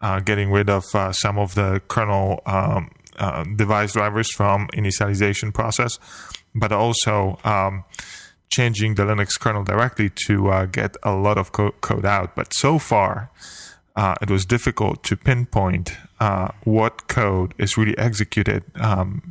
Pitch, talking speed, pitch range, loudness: 105 Hz, 150 wpm, 100-110 Hz, -21 LUFS